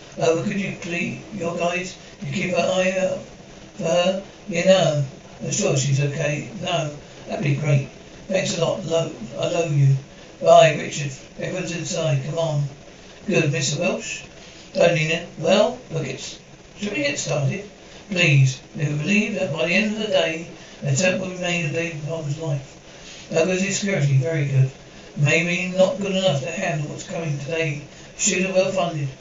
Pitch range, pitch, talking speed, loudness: 150-185 Hz, 170 Hz, 180 wpm, -22 LUFS